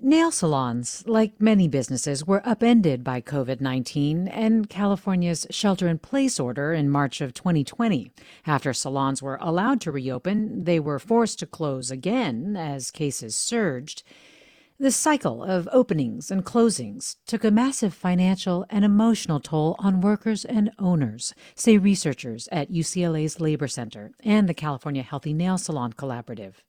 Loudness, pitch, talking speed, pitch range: -24 LUFS, 170 Hz, 140 wpm, 140-210 Hz